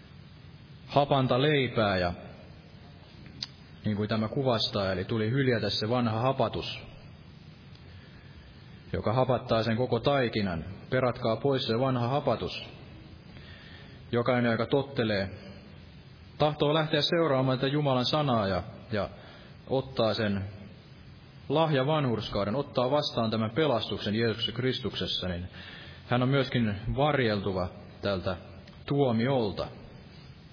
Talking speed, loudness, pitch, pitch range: 100 wpm, -29 LUFS, 115 Hz, 100-135 Hz